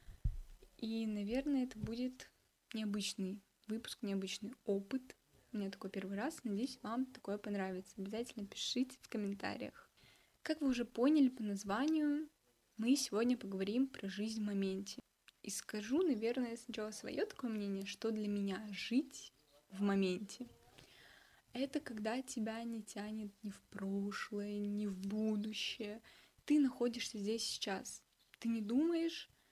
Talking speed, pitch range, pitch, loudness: 130 wpm, 200-255 Hz, 220 Hz, -40 LUFS